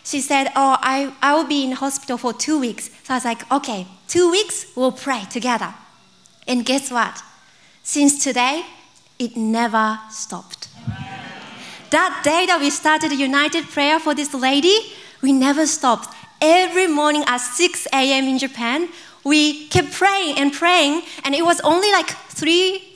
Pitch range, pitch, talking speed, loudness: 250-320 Hz, 280 Hz, 160 wpm, -18 LUFS